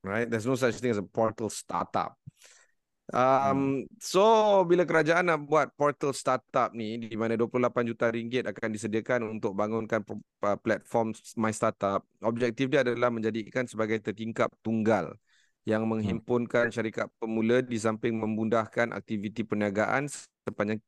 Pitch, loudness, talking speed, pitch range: 115 Hz, -28 LUFS, 135 wpm, 110-125 Hz